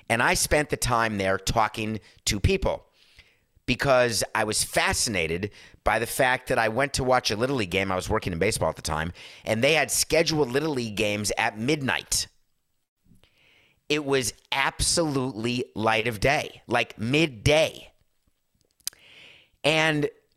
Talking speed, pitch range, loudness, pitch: 150 wpm, 105-135 Hz, -24 LUFS, 115 Hz